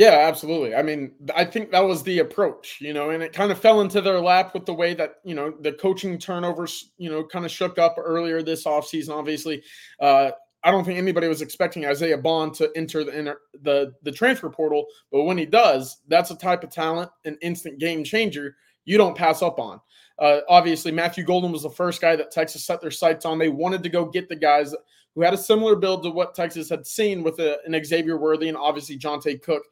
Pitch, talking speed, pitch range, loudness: 165 Hz, 230 wpm, 155-180 Hz, -22 LUFS